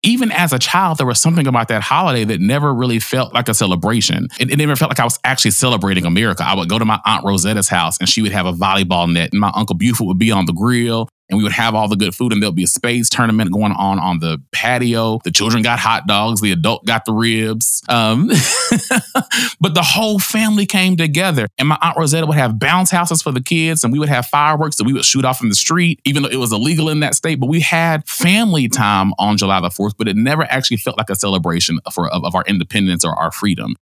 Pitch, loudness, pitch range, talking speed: 115 Hz, -14 LUFS, 105-150 Hz, 255 wpm